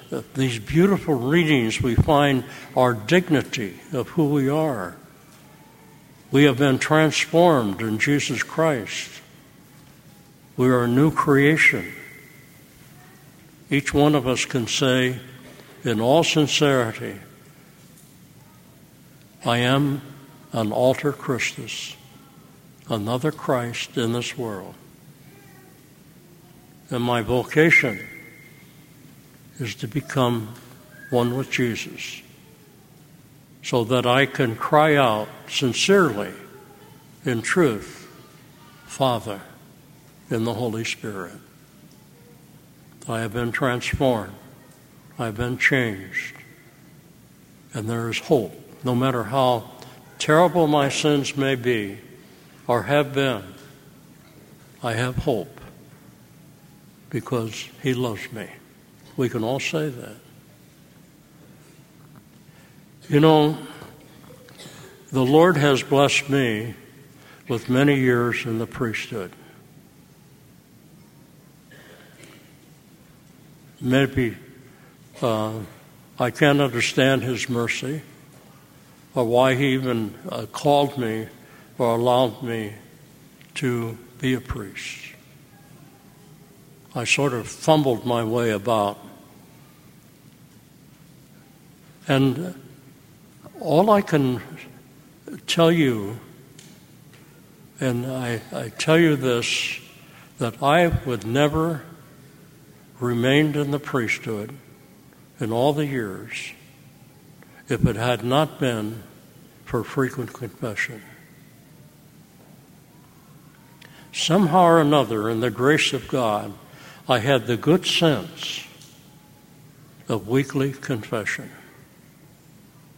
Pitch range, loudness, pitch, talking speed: 125-155 Hz, -22 LUFS, 140 Hz, 90 wpm